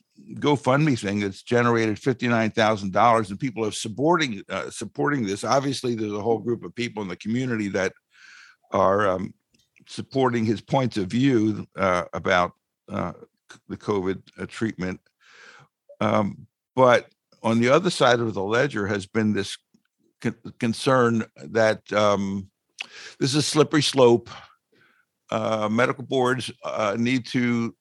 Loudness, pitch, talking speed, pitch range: -23 LUFS, 115 Hz, 140 wpm, 100-125 Hz